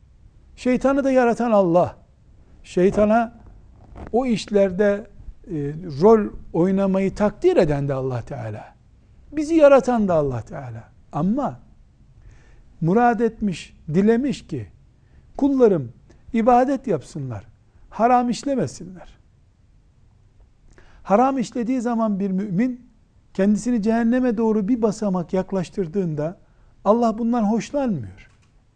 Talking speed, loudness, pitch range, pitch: 90 wpm, -20 LUFS, 140-235 Hz, 200 Hz